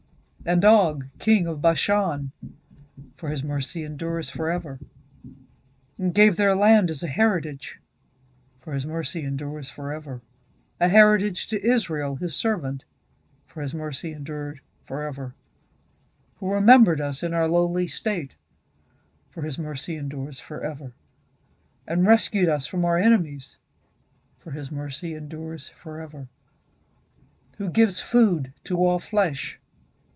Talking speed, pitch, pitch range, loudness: 125 wpm, 160 Hz, 140-180 Hz, -24 LUFS